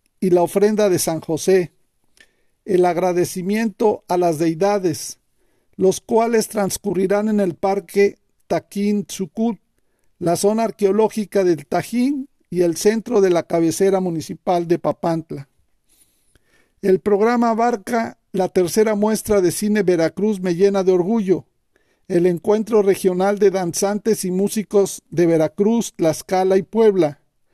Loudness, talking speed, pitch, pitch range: -19 LUFS, 125 wpm, 195 Hz, 175-210 Hz